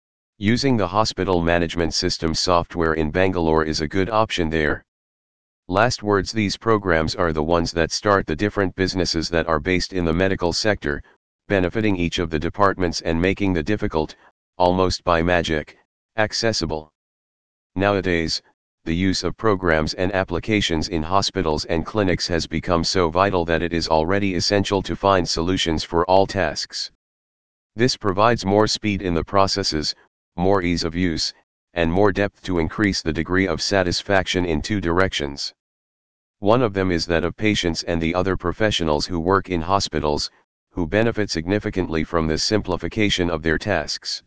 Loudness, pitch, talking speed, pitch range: -21 LUFS, 90 Hz, 160 wpm, 80-100 Hz